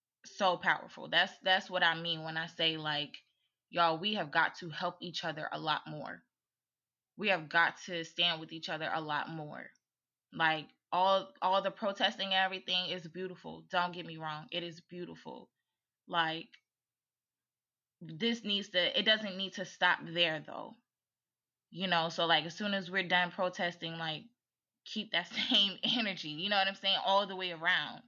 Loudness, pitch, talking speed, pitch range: -33 LUFS, 175 Hz, 180 wpm, 165-190 Hz